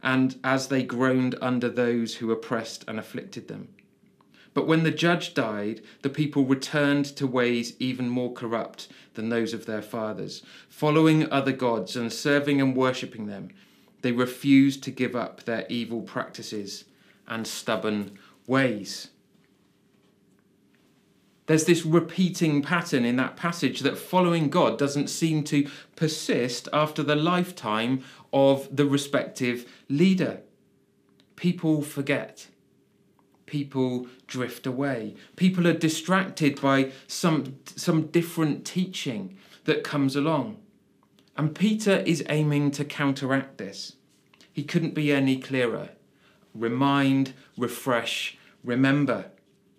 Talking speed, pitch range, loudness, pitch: 120 wpm, 125-155 Hz, -26 LUFS, 135 Hz